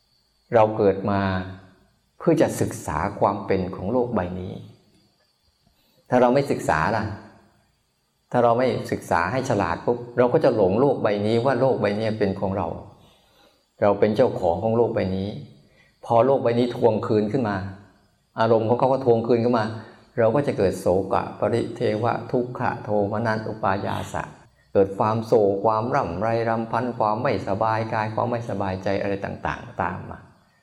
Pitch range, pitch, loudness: 100-120 Hz, 110 Hz, -23 LUFS